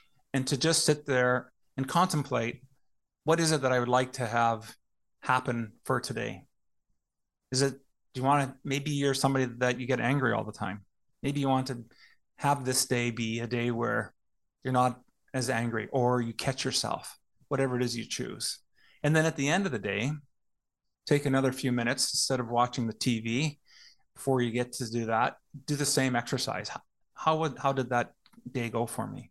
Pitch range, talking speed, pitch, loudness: 120-140 Hz, 195 wpm, 130 Hz, -30 LUFS